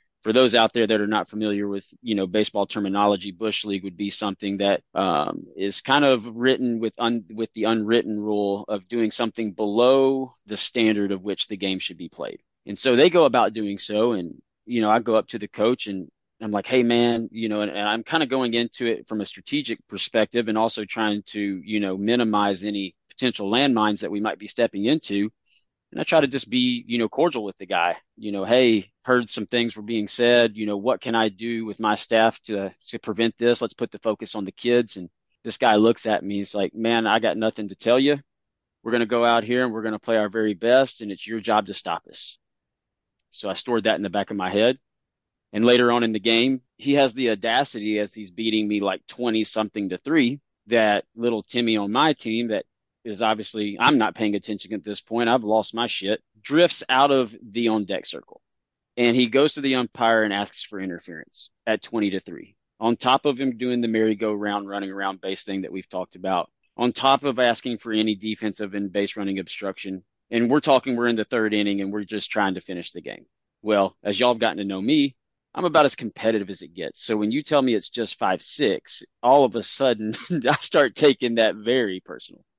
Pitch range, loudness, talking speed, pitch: 105-120 Hz, -23 LUFS, 230 wpm, 110 Hz